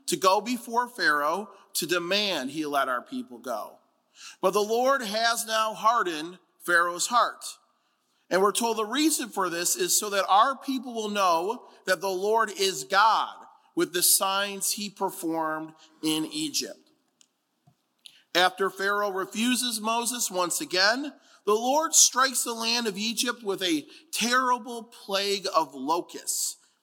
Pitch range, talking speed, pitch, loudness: 185-245 Hz, 145 wpm, 210 Hz, -25 LUFS